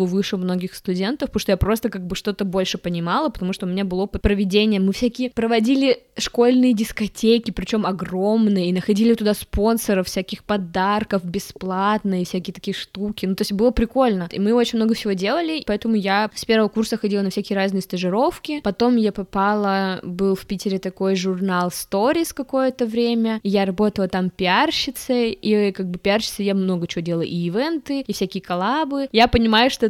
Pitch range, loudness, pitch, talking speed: 190-230 Hz, -21 LUFS, 205 Hz, 175 wpm